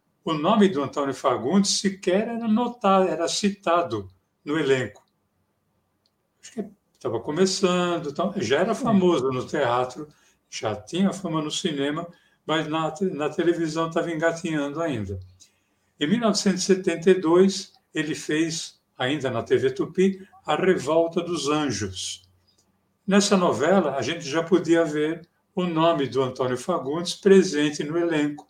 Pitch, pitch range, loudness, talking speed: 165 Hz, 145-190 Hz, -23 LUFS, 125 wpm